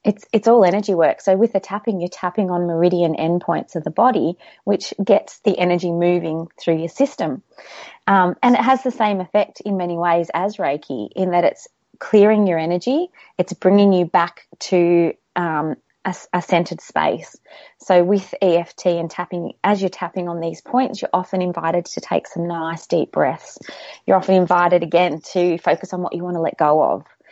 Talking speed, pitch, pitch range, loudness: 190 wpm, 180 Hz, 170-200 Hz, -19 LUFS